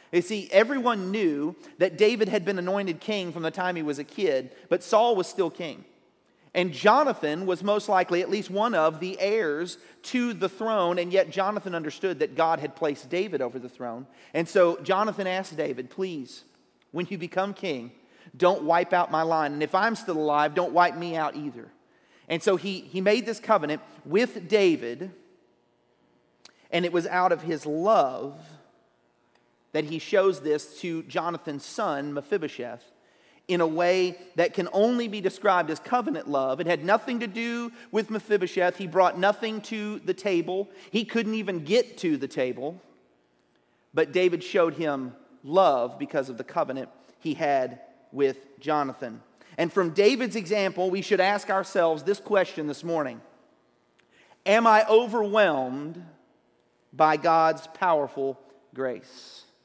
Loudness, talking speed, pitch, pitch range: -26 LUFS, 160 wpm, 180 Hz, 155-205 Hz